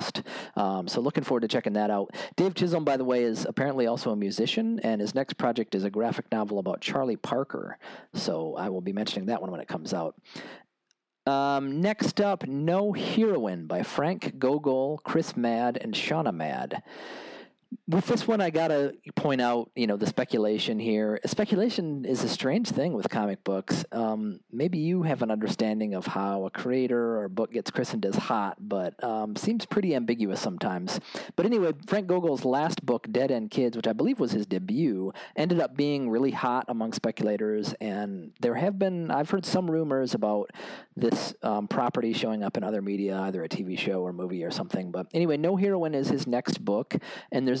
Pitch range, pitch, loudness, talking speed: 105-165 Hz, 125 Hz, -28 LUFS, 195 wpm